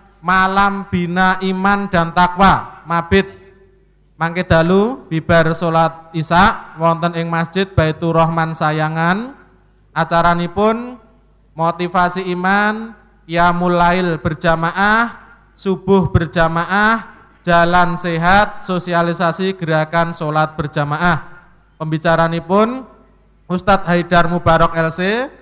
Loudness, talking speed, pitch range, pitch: -15 LUFS, 90 wpm, 165-195 Hz, 175 Hz